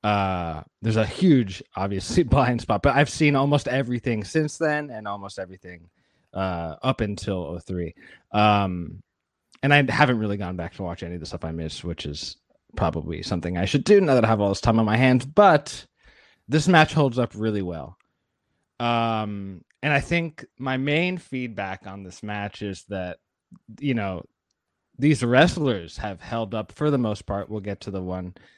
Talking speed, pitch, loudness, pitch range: 185 wpm, 105 Hz, -23 LUFS, 95-130 Hz